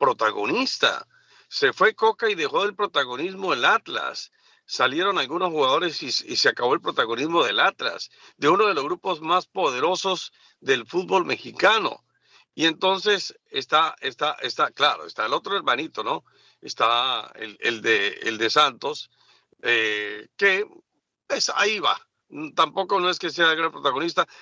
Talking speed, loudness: 150 wpm, -22 LUFS